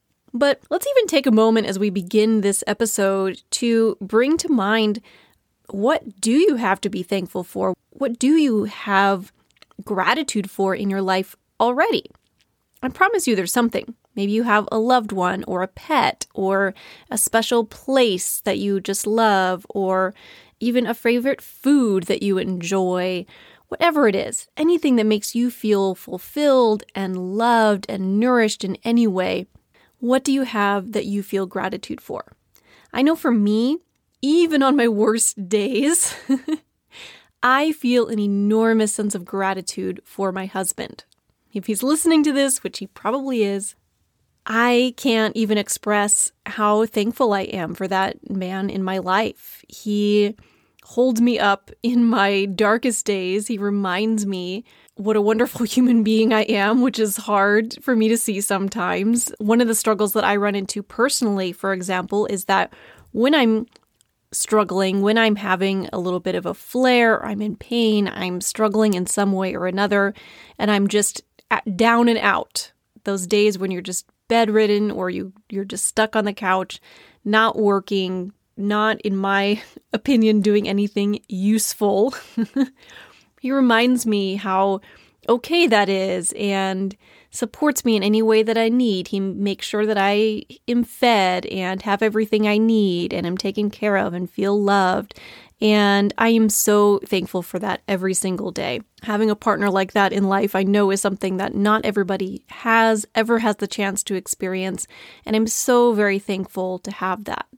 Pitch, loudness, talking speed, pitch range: 210 Hz, -20 LUFS, 165 wpm, 195-230 Hz